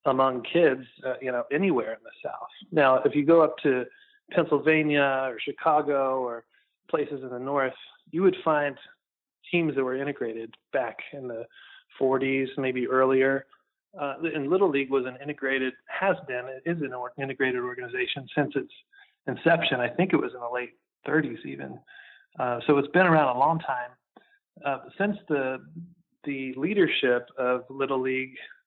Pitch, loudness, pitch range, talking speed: 140 Hz, -26 LUFS, 130-165 Hz, 165 wpm